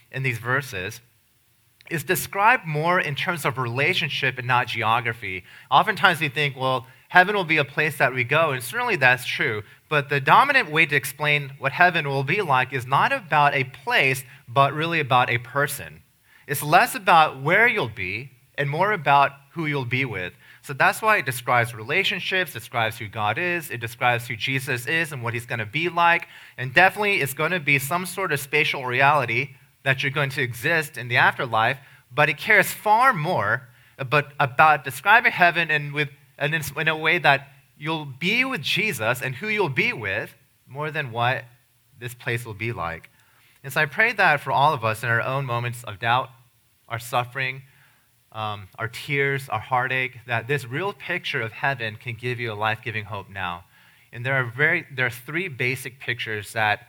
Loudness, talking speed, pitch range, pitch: -22 LUFS, 190 wpm, 120-150 Hz, 135 Hz